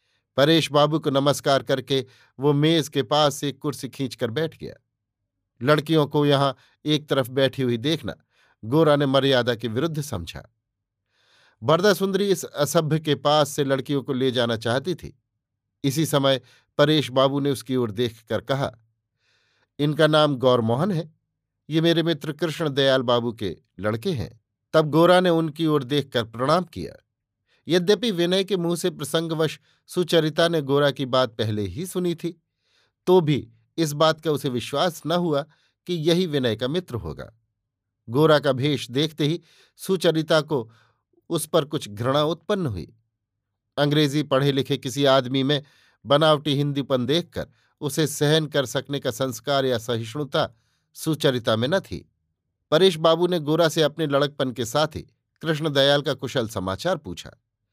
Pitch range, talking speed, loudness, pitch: 120-160 Hz, 155 wpm, -22 LUFS, 140 Hz